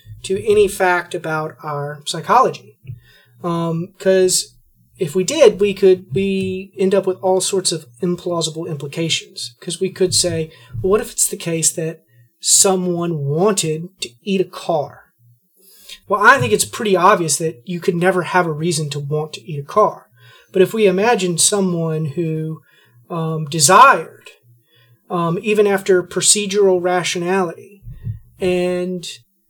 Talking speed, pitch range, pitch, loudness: 145 wpm, 155-190 Hz, 175 Hz, -16 LUFS